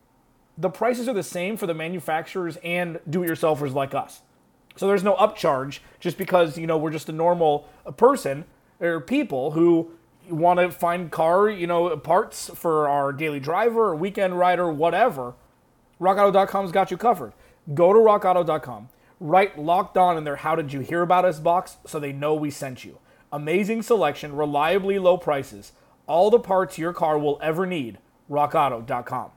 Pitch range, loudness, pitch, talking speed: 150-185 Hz, -22 LUFS, 170 Hz, 170 wpm